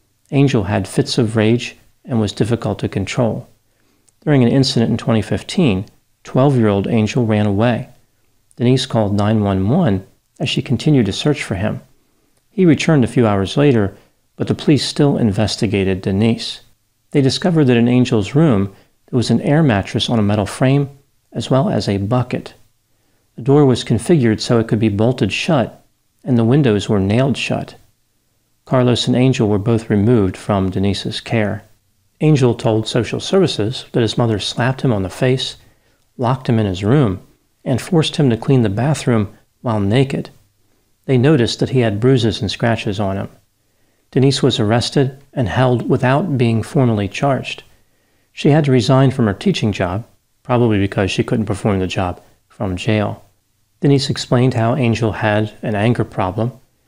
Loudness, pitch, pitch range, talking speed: -16 LUFS, 115 Hz, 105-130 Hz, 165 wpm